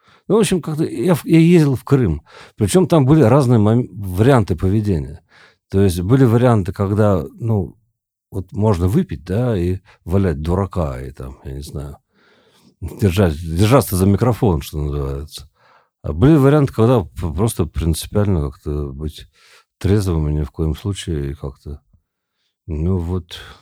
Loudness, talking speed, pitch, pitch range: -17 LUFS, 145 wpm, 95 Hz, 80-115 Hz